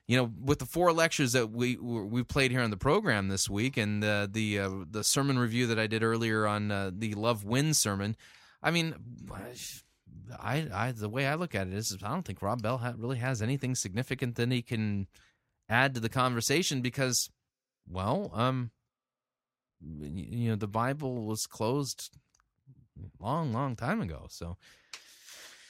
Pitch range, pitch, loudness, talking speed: 105-130 Hz, 120 Hz, -31 LUFS, 175 wpm